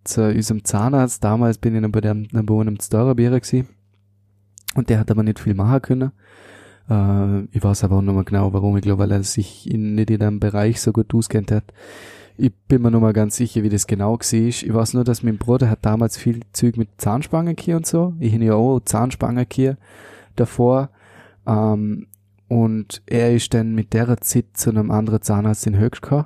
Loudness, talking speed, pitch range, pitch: -19 LUFS, 205 wpm, 105-120 Hz, 110 Hz